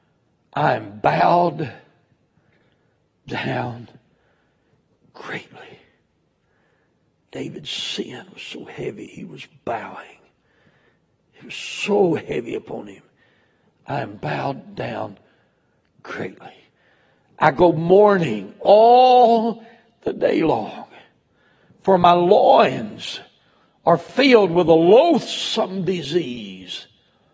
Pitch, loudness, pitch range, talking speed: 175 Hz, -18 LUFS, 155-210 Hz, 90 wpm